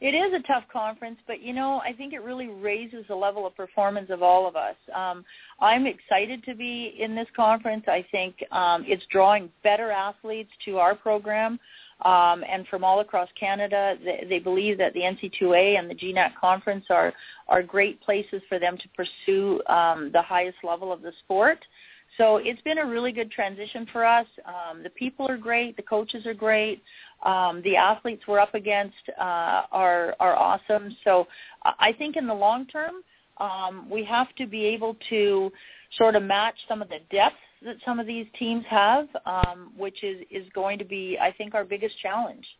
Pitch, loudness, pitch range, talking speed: 210 Hz, -25 LUFS, 185-235 Hz, 195 wpm